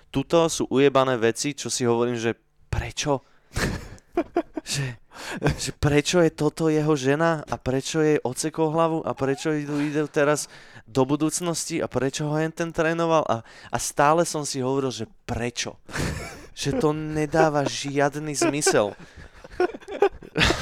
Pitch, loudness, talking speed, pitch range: 150 Hz, -24 LUFS, 135 wpm, 135-160 Hz